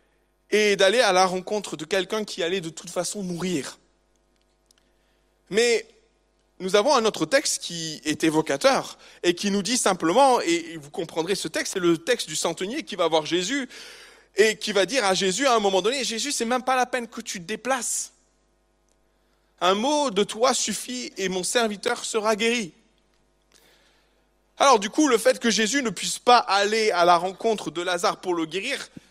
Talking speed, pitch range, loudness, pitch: 185 wpm, 175-240 Hz, -23 LUFS, 200 Hz